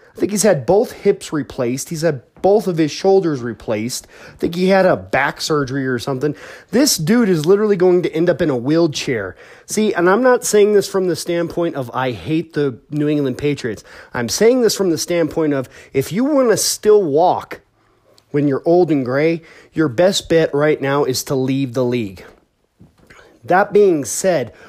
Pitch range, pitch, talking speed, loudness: 140-190 Hz, 165 Hz, 195 wpm, -16 LUFS